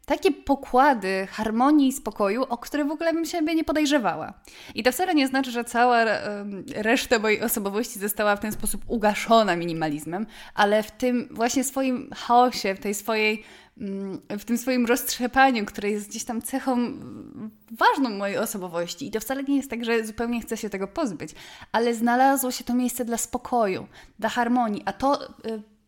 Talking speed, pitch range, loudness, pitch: 170 wpm, 215-260 Hz, -24 LUFS, 235 Hz